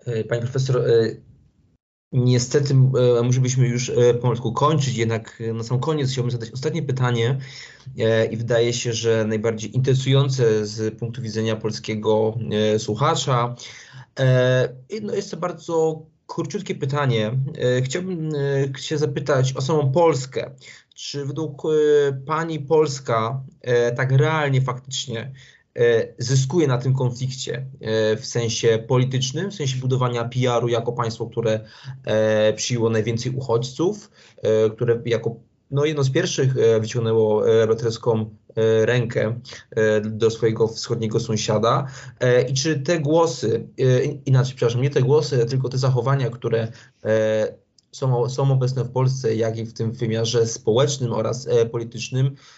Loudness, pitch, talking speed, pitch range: -21 LUFS, 125 Hz, 115 wpm, 115-140 Hz